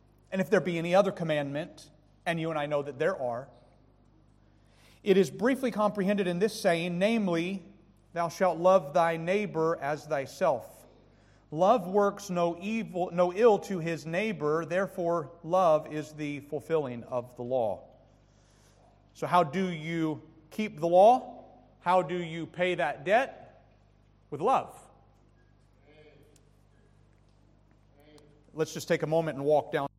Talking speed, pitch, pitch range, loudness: 140 wpm, 160 Hz, 130-180 Hz, -29 LUFS